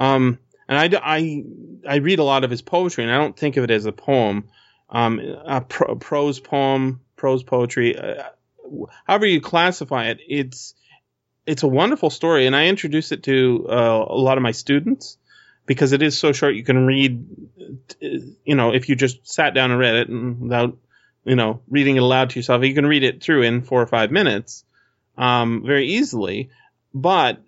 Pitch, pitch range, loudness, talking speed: 130 Hz, 125-145 Hz, -19 LUFS, 195 wpm